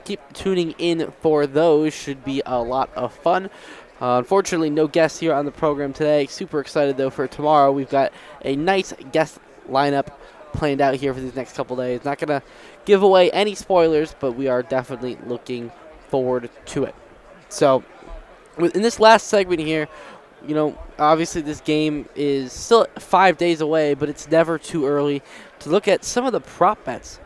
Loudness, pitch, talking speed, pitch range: -20 LUFS, 150 Hz, 185 wpm, 135-165 Hz